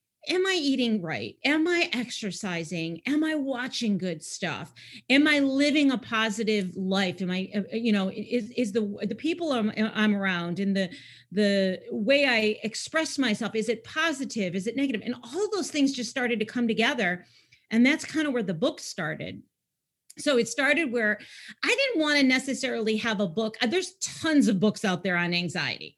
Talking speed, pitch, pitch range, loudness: 185 wpm, 230 Hz, 200-275 Hz, -26 LUFS